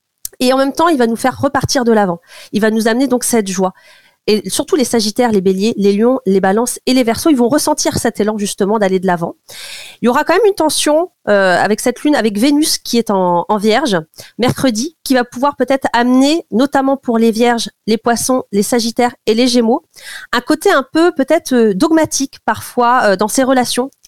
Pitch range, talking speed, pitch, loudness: 215-275 Hz, 215 wpm, 245 Hz, -13 LUFS